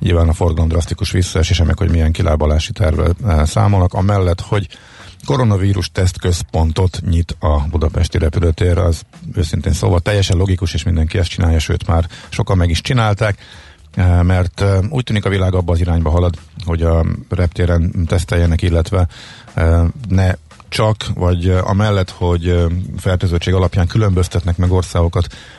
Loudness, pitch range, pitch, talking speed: -16 LUFS, 85-100 Hz, 90 Hz, 135 wpm